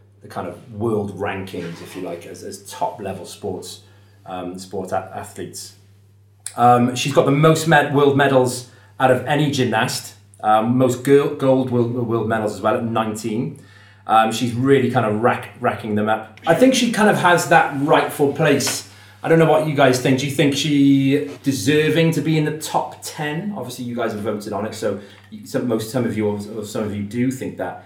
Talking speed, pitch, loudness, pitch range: 205 wpm, 120 Hz, -18 LUFS, 105-140 Hz